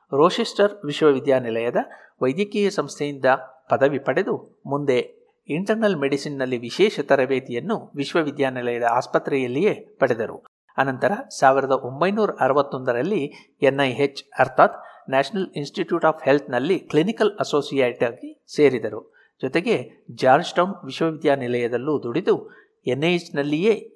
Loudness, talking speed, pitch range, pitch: -22 LUFS, 95 wpm, 130-190 Hz, 145 Hz